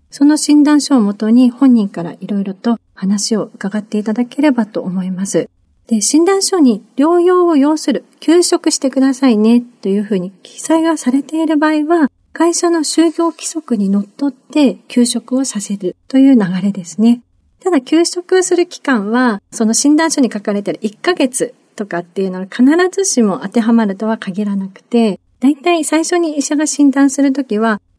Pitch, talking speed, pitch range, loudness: 255 Hz, 345 characters per minute, 210-310 Hz, -14 LUFS